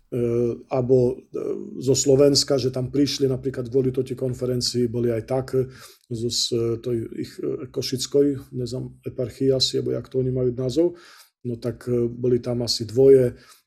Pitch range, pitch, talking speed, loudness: 120-130 Hz, 125 Hz, 135 wpm, -23 LUFS